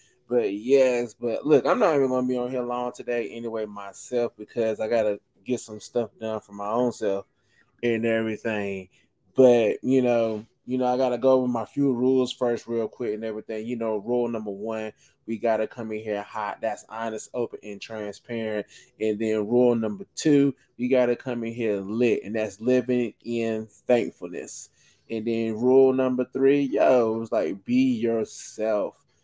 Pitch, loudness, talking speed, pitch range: 115 Hz, -25 LUFS, 180 wpm, 110-125 Hz